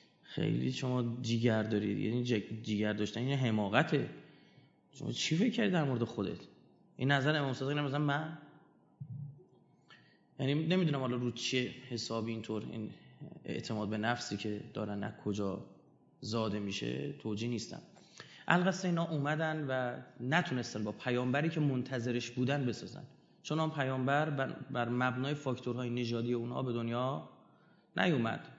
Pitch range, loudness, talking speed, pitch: 110-140 Hz, -35 LUFS, 130 wpm, 125 Hz